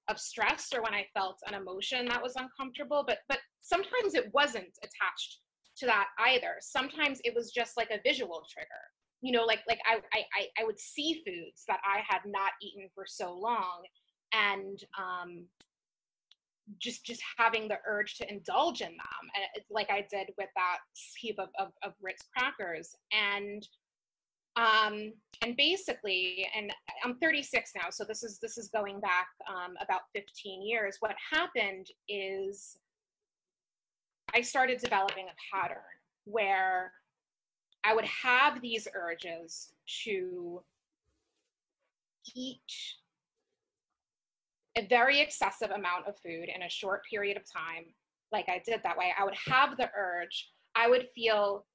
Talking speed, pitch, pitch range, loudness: 150 wpm, 215 Hz, 195-250 Hz, -32 LUFS